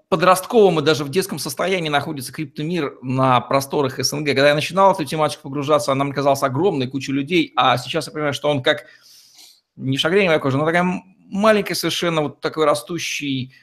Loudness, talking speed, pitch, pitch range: -19 LUFS, 180 wpm, 150 Hz, 140-170 Hz